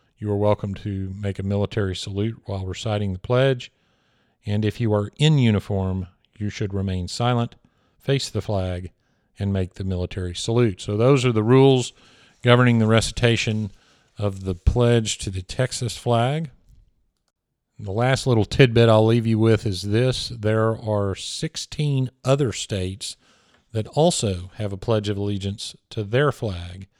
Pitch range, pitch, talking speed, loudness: 100-120 Hz, 110 Hz, 160 wpm, -22 LUFS